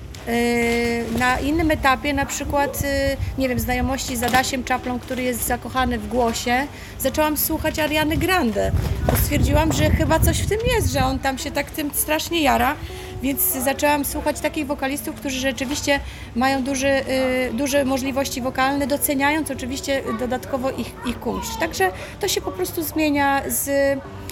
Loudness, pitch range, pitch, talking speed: -21 LUFS, 255-295 Hz, 275 Hz, 150 wpm